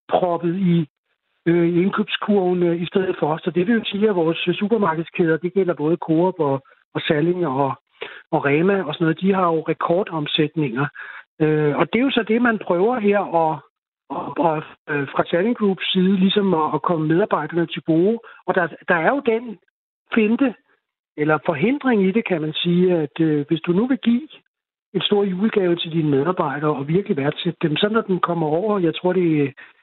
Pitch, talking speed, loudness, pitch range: 175 Hz, 200 wpm, -20 LUFS, 160-200 Hz